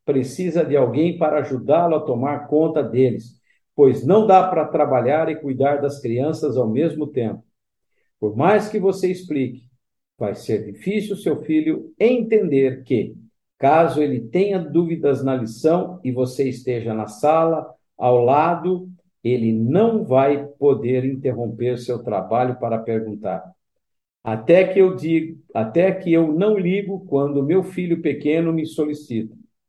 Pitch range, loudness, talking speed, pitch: 125-175 Hz, -20 LUFS, 140 wpm, 150 Hz